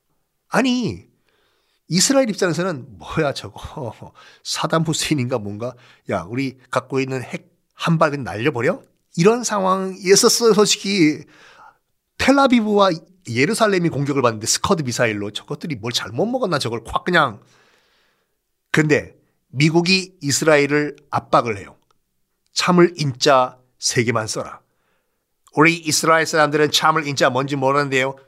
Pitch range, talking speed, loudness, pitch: 130-190 Hz, 280 characters per minute, -18 LUFS, 155 Hz